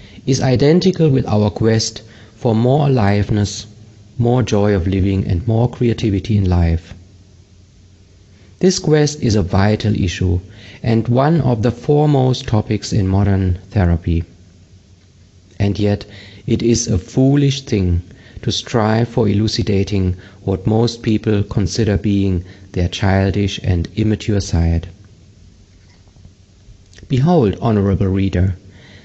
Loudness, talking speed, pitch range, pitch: -16 LUFS, 115 wpm, 95-115 Hz, 100 Hz